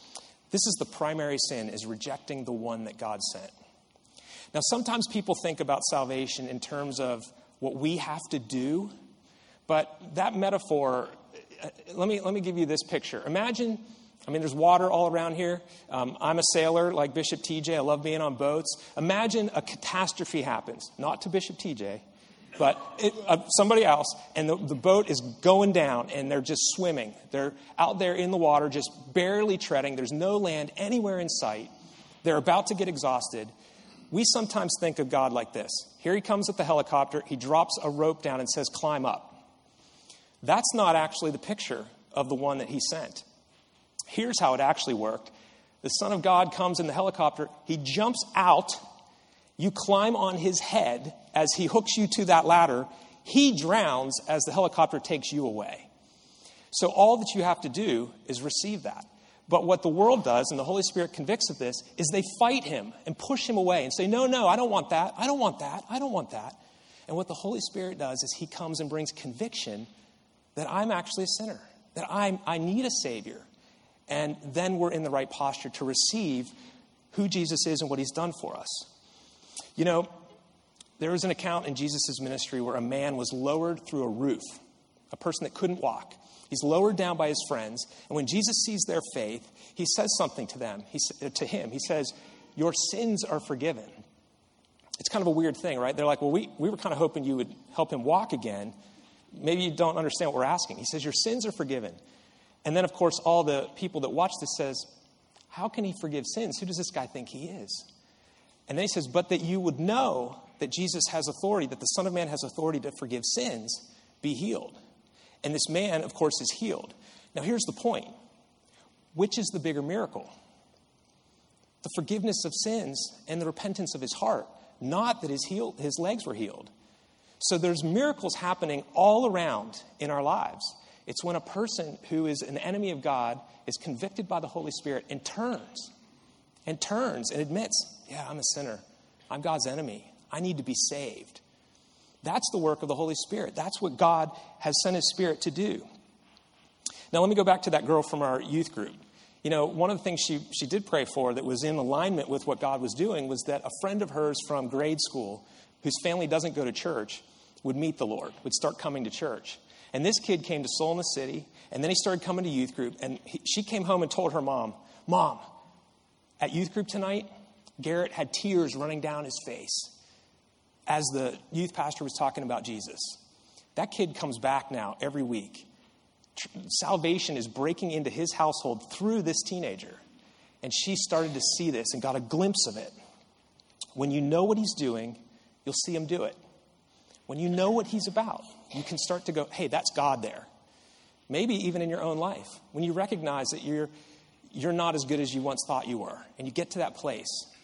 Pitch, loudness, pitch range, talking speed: 165 Hz, -29 LUFS, 145-195 Hz, 200 wpm